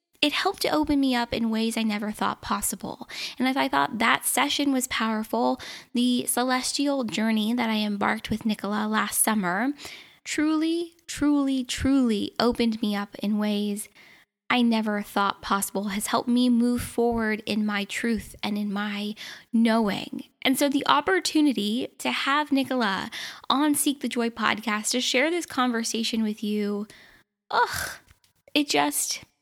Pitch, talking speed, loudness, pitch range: 230 Hz, 155 wpm, -25 LUFS, 210-270 Hz